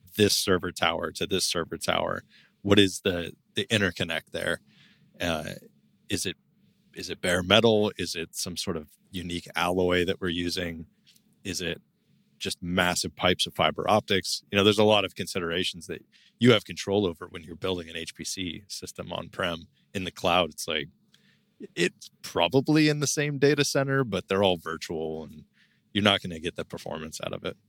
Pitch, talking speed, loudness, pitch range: 95 Hz, 185 wpm, -27 LUFS, 85-105 Hz